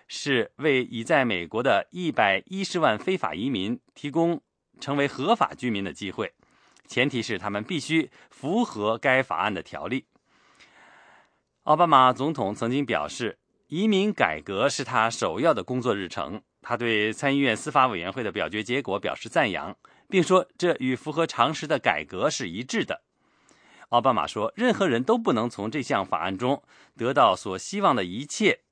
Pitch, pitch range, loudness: 140 Hz, 120-180 Hz, -25 LUFS